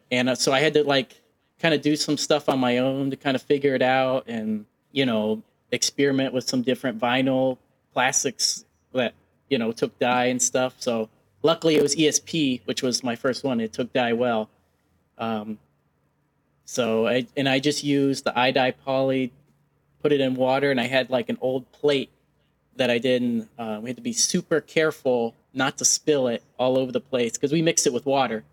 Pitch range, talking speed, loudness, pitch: 120-140 Hz, 205 wpm, -23 LUFS, 130 Hz